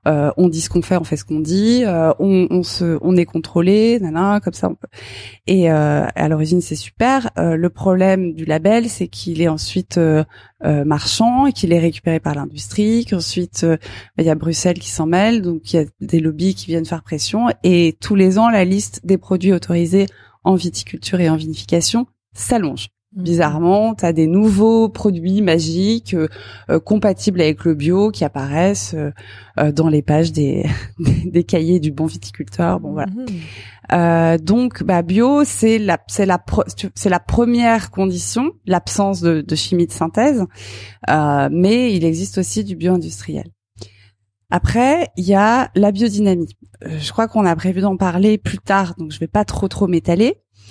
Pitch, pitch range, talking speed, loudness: 175 Hz, 155-195 Hz, 185 wpm, -16 LUFS